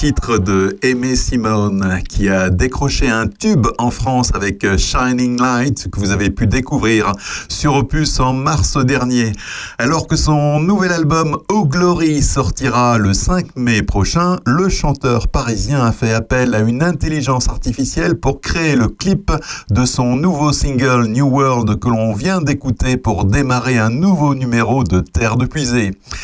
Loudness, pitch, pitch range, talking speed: -15 LUFS, 125 Hz, 110-145 Hz, 160 wpm